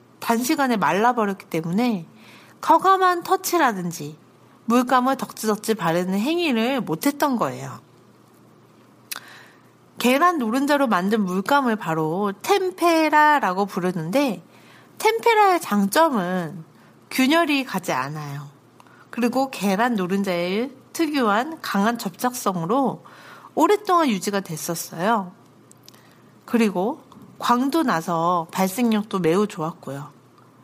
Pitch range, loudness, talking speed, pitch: 180-275 Hz, -21 LUFS, 240 characters per minute, 225 Hz